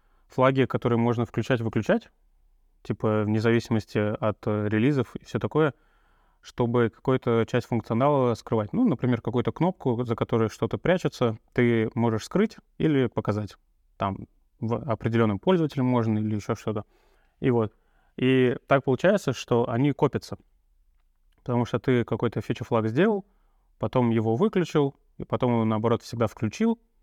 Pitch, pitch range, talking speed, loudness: 120 Hz, 110-130 Hz, 135 wpm, -26 LUFS